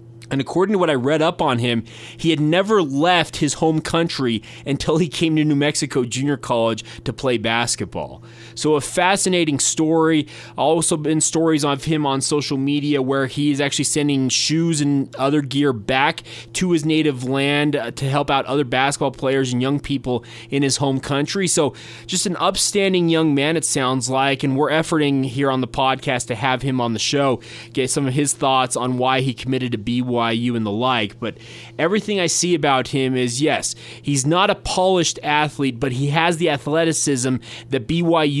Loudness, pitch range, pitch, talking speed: -19 LUFS, 125-155 Hz, 140 Hz, 190 wpm